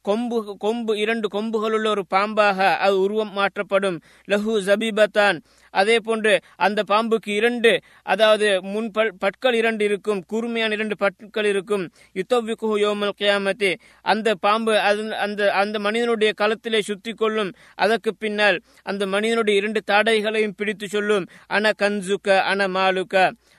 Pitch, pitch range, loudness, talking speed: 210 Hz, 200-220 Hz, -21 LUFS, 125 wpm